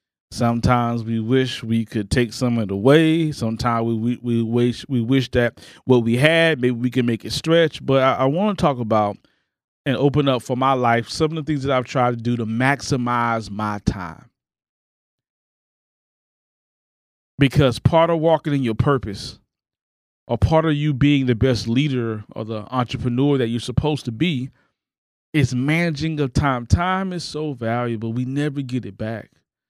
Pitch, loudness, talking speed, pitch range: 125 Hz, -20 LUFS, 180 wpm, 115-145 Hz